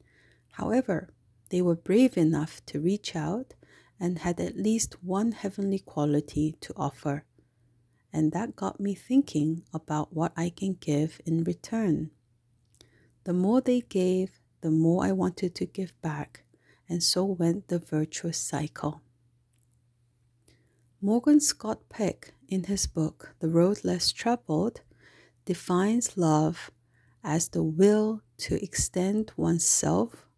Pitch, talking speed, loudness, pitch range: 170 Hz, 125 wpm, -28 LUFS, 150-195 Hz